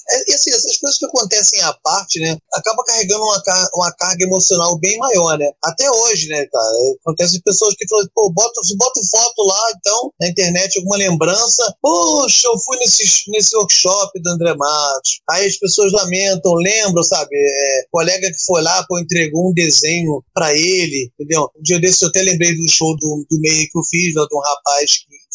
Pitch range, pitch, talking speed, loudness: 160-205 Hz, 180 Hz, 195 wpm, -13 LUFS